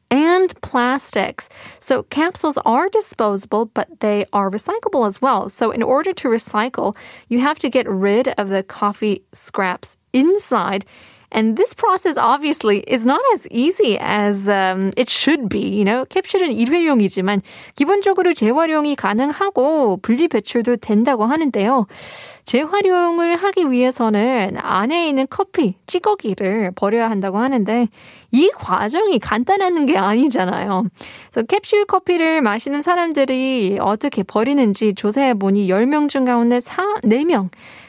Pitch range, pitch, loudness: 210-325 Hz, 255 Hz, -17 LUFS